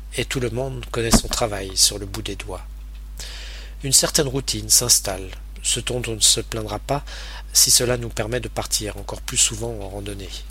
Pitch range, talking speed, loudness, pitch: 95-120 Hz, 200 wpm, -19 LUFS, 110 Hz